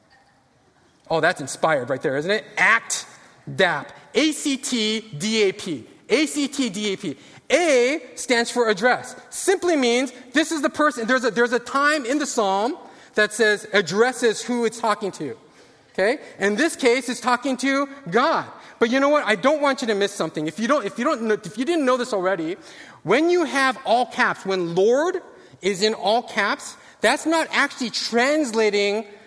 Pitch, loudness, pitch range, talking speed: 245 Hz, -21 LUFS, 215-280 Hz, 190 wpm